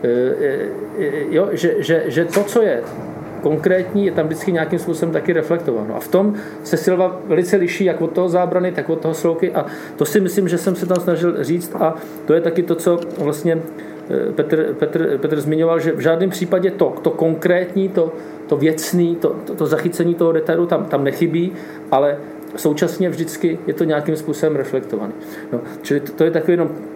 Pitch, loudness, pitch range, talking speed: 170 Hz, -18 LUFS, 155-180 Hz, 185 wpm